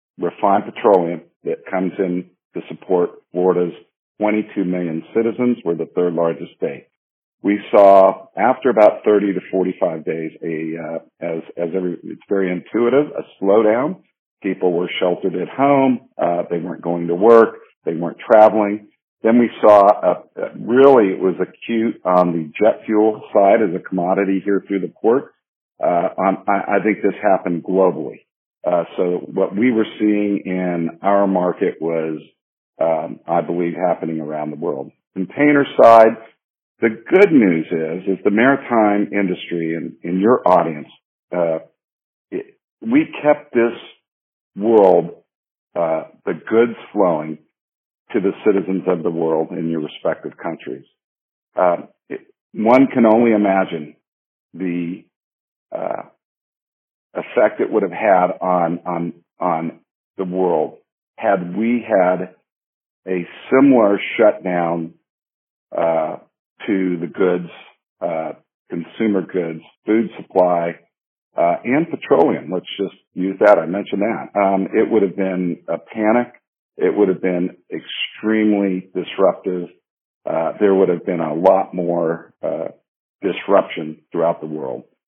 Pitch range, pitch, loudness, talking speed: 85-105 Hz, 95 Hz, -17 LUFS, 140 wpm